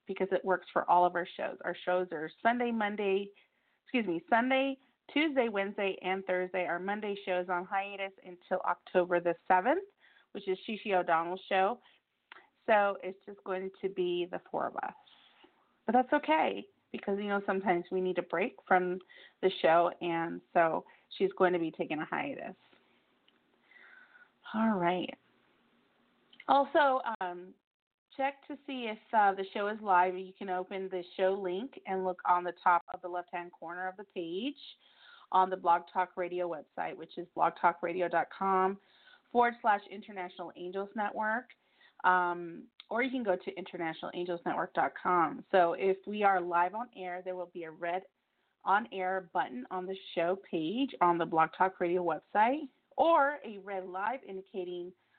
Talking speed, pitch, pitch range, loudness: 165 wpm, 185 Hz, 180-210 Hz, -32 LUFS